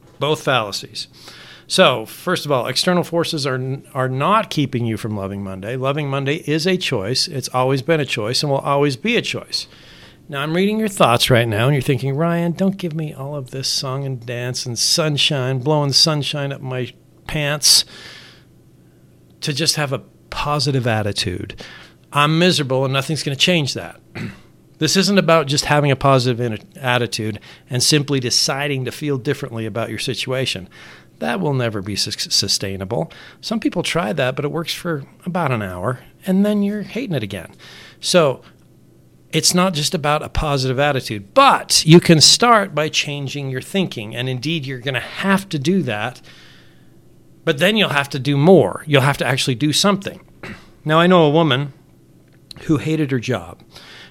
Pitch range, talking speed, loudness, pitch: 125-160 Hz, 175 wpm, -18 LUFS, 140 Hz